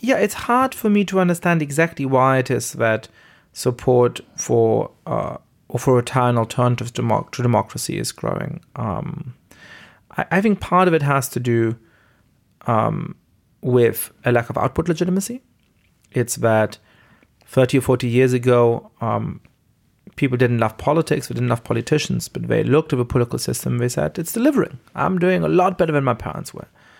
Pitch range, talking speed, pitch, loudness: 120-165 Hz, 175 wpm, 130 Hz, -20 LUFS